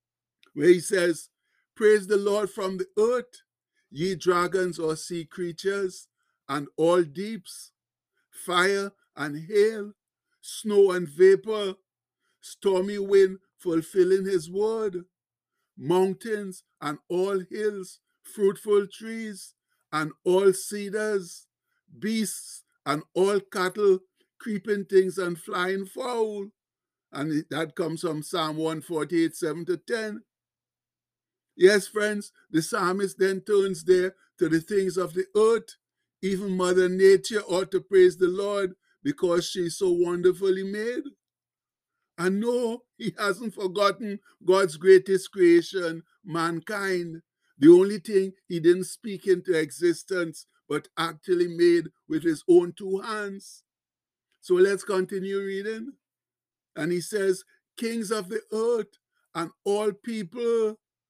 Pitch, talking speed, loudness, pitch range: 195 Hz, 115 wpm, -25 LUFS, 175-210 Hz